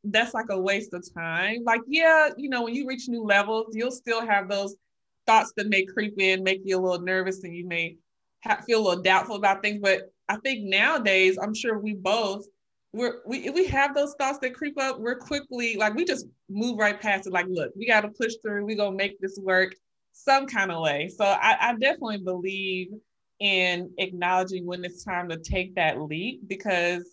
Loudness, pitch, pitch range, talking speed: -25 LUFS, 200 Hz, 185-230 Hz, 215 wpm